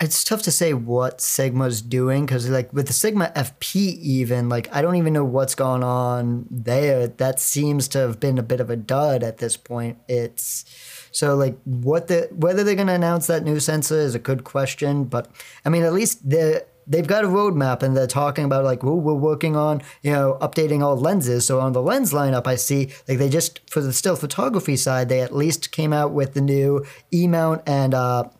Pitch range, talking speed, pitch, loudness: 130-155 Hz, 220 wpm, 140 Hz, -21 LUFS